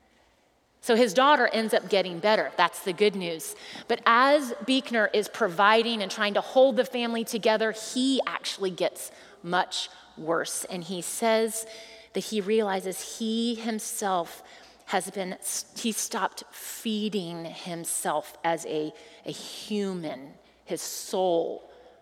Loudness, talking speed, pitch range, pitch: -27 LUFS, 130 wpm, 185-230 Hz, 210 Hz